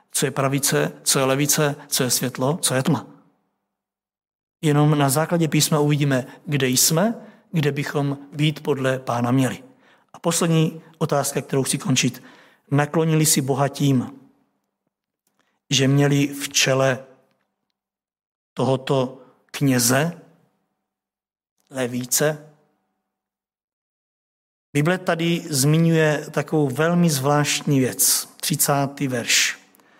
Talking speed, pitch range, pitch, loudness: 100 wpm, 135-155 Hz, 145 Hz, -20 LUFS